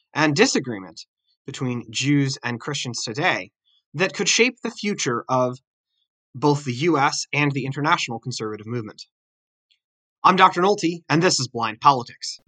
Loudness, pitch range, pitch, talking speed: -21 LUFS, 120-170 Hz, 140 Hz, 140 wpm